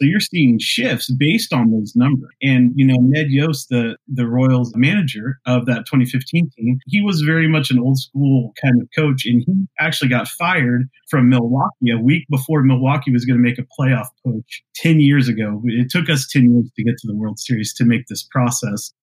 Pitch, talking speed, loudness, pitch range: 130 Hz, 210 wpm, -16 LUFS, 120-145 Hz